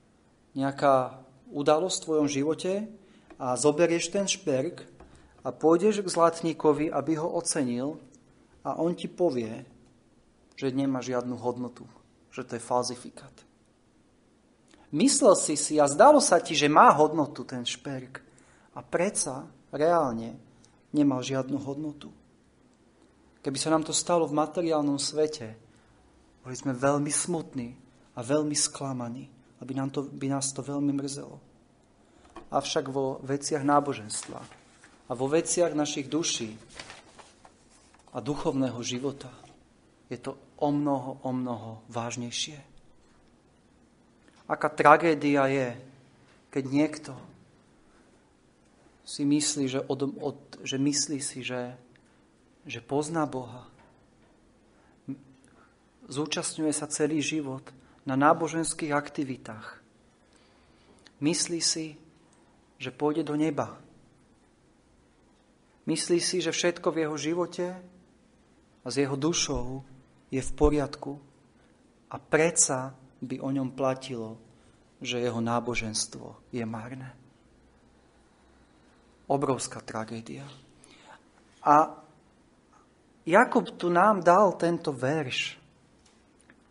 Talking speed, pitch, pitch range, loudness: 105 wpm, 140 Hz, 125-155 Hz, -27 LUFS